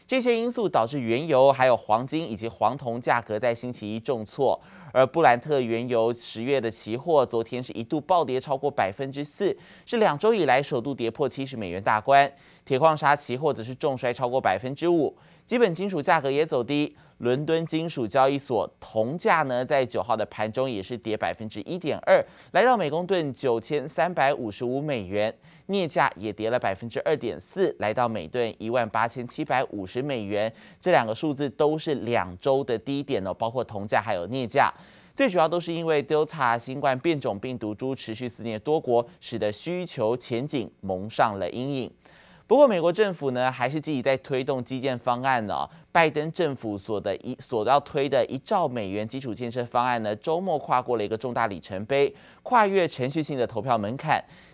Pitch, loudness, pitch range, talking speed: 130 Hz, -25 LUFS, 115-150 Hz, 295 characters per minute